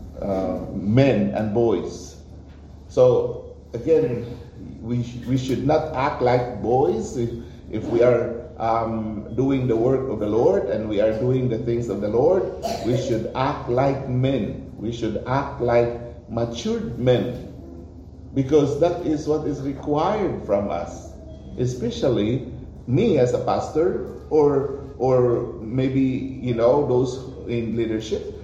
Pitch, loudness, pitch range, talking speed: 120 Hz, -22 LUFS, 115-135 Hz, 140 wpm